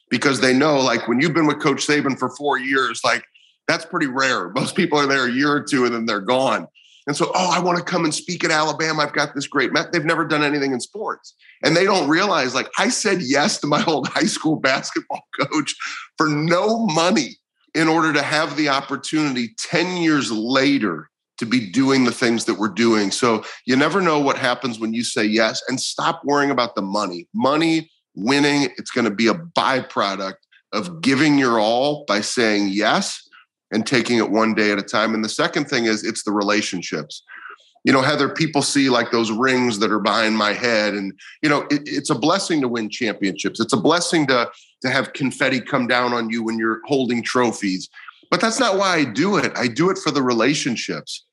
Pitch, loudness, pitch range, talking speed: 130 Hz, -19 LUFS, 110-150 Hz, 215 wpm